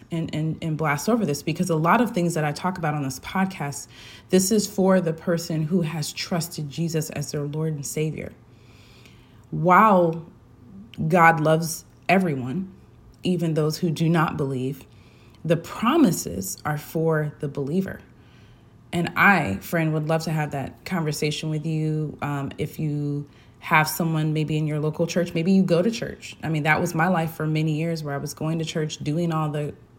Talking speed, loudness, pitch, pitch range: 185 wpm, -23 LUFS, 155 Hz, 145-170 Hz